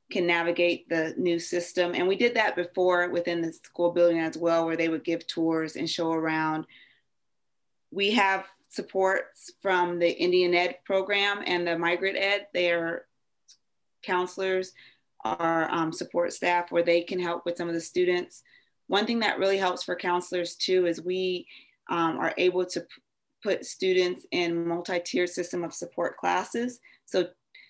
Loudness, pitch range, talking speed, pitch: -27 LUFS, 170-190 Hz, 160 wpm, 175 Hz